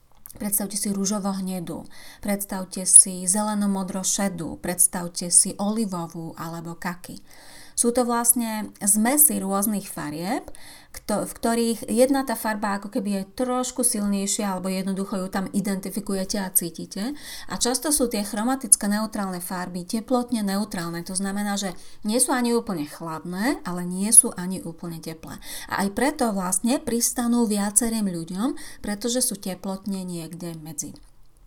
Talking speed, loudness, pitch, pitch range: 135 wpm, -22 LUFS, 200 Hz, 185-235 Hz